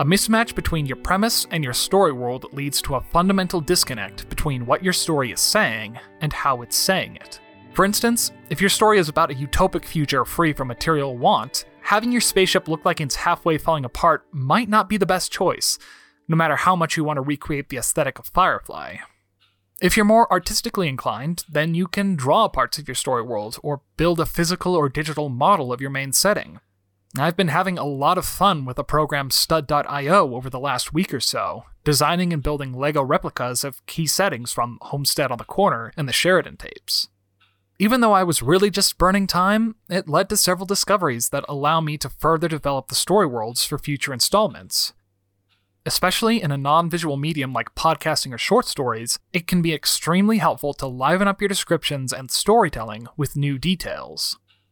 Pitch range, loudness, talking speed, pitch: 135-185 Hz, -20 LUFS, 195 wpm, 155 Hz